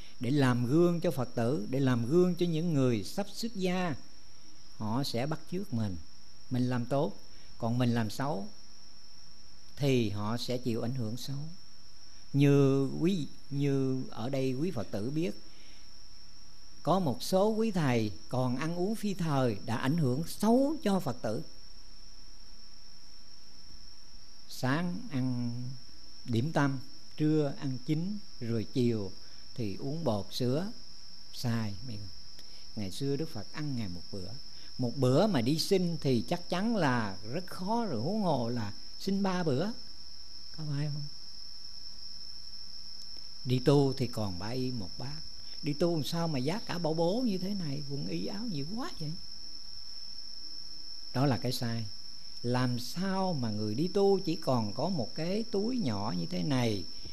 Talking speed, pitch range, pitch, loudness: 155 wpm, 110-165 Hz, 130 Hz, -32 LUFS